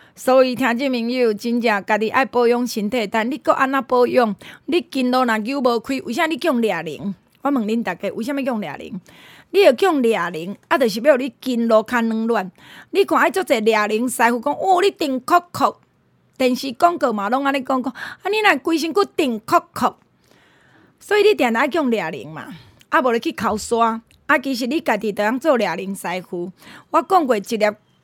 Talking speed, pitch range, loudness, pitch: 280 characters per minute, 220-295 Hz, -19 LUFS, 250 Hz